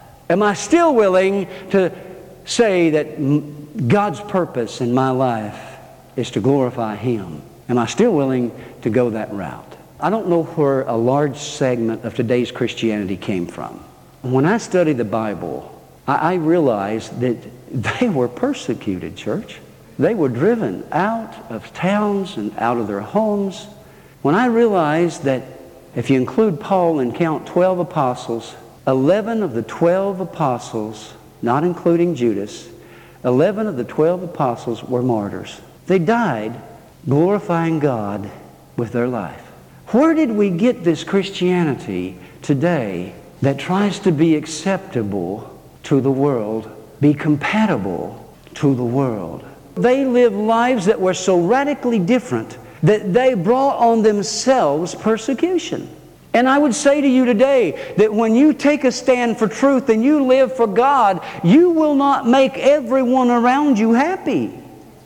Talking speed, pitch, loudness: 145 wpm, 170 Hz, -18 LUFS